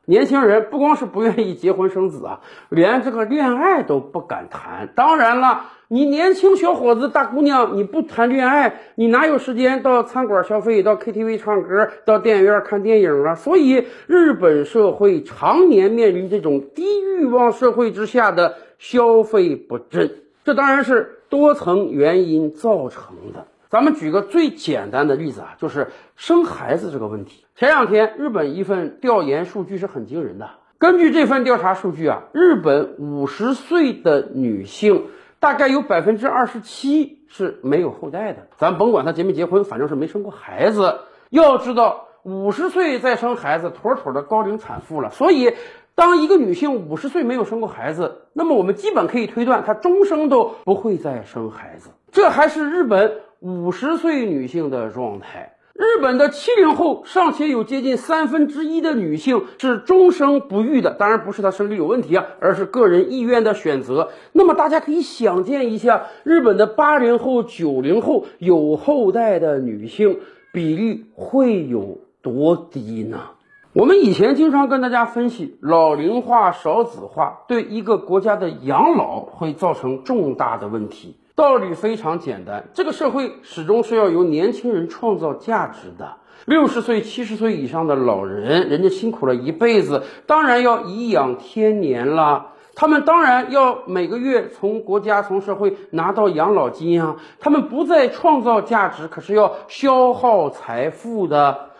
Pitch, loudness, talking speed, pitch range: 240 Hz, -17 LUFS, 260 characters per minute, 200-300 Hz